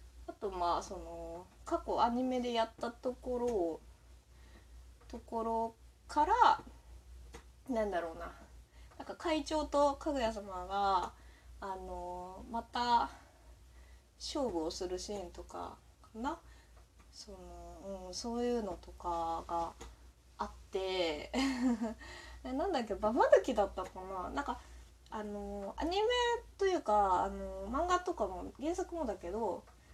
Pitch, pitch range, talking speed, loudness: 210 Hz, 175-270 Hz, 215 characters per minute, -36 LUFS